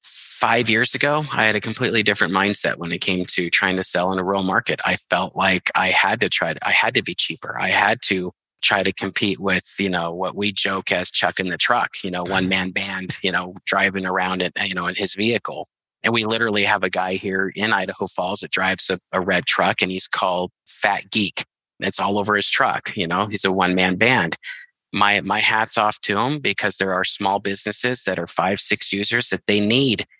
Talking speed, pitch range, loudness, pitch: 230 wpm, 95-105 Hz, -20 LUFS, 100 Hz